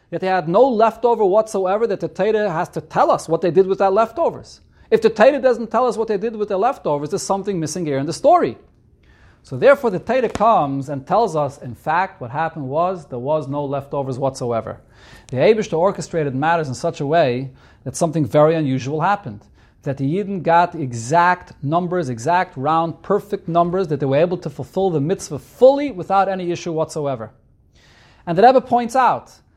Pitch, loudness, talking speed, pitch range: 170 Hz, -18 LUFS, 205 wpm, 145-200 Hz